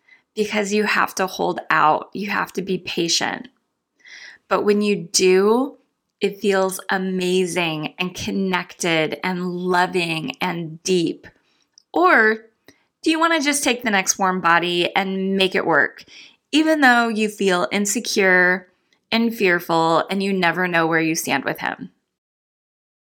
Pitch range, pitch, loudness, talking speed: 180-210 Hz, 190 Hz, -19 LUFS, 140 wpm